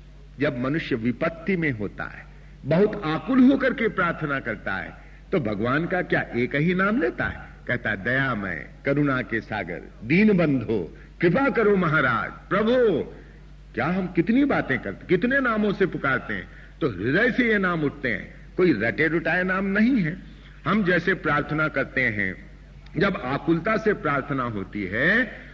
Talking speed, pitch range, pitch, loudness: 160 wpm, 135-190 Hz, 155 Hz, -23 LUFS